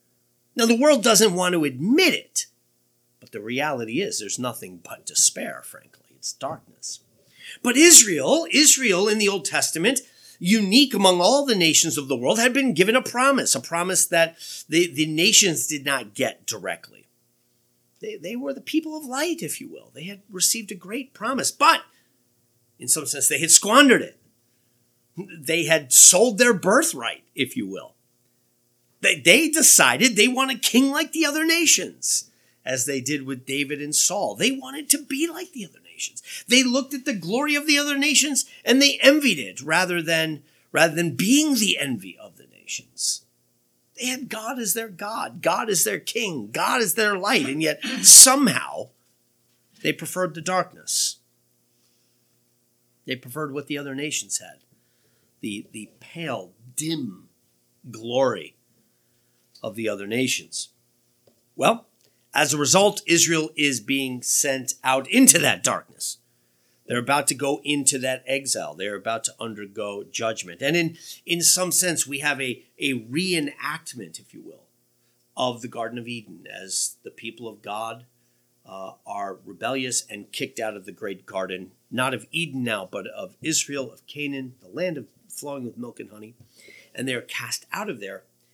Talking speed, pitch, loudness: 165 wpm, 150 Hz, -19 LUFS